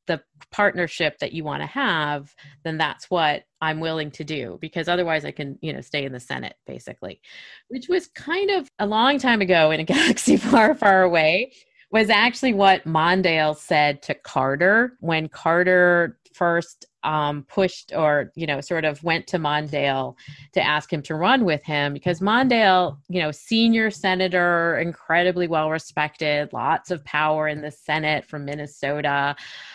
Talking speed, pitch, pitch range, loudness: 165 wpm, 160 Hz, 150-185 Hz, -21 LUFS